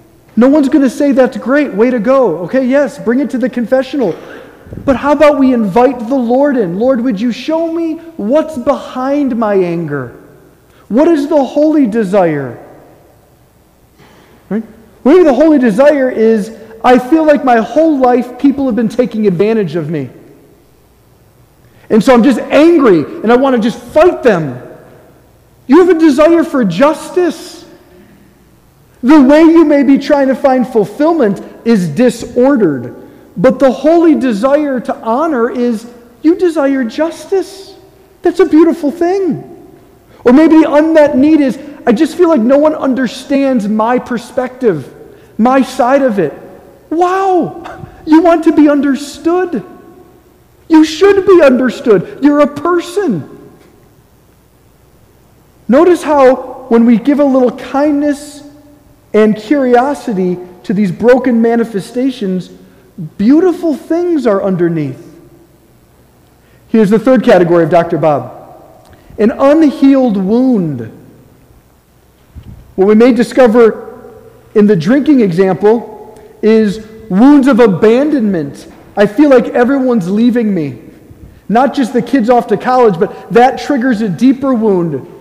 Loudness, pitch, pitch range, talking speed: -10 LUFS, 255 Hz, 215-290 Hz, 135 wpm